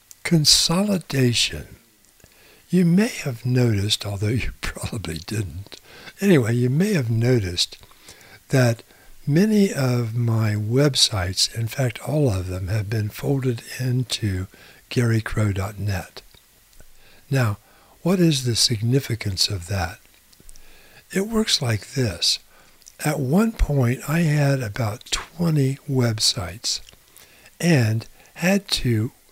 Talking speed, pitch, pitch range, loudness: 105 wpm, 120 Hz, 105-145 Hz, -21 LUFS